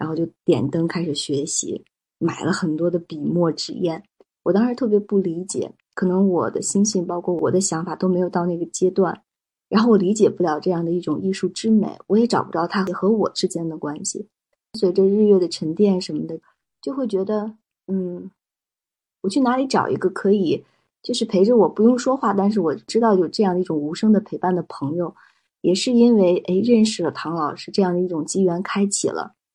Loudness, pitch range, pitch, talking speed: -20 LUFS, 170-205 Hz, 185 Hz, 300 characters per minute